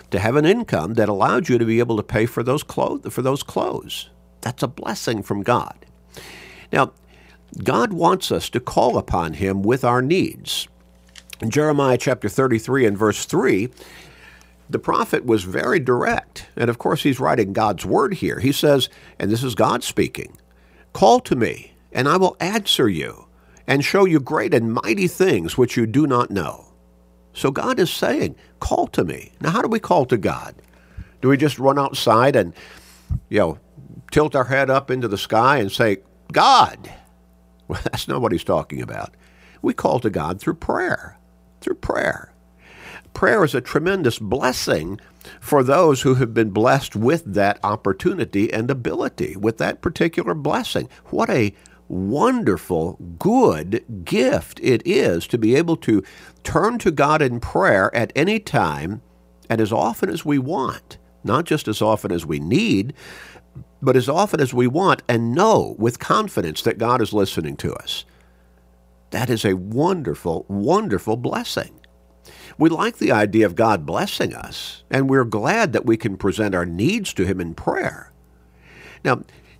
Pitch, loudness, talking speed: 110 Hz, -20 LUFS, 170 wpm